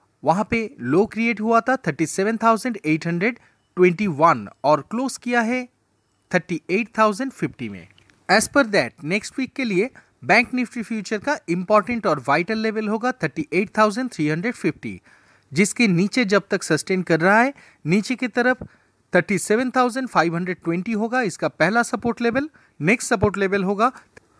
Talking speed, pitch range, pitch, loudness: 125 wpm, 165-235 Hz, 210 Hz, -21 LUFS